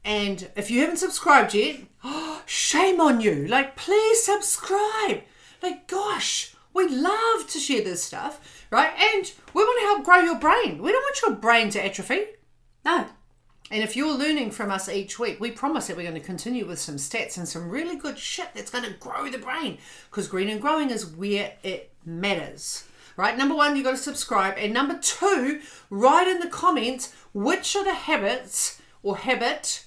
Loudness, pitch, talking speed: -24 LUFS, 280 Hz, 190 wpm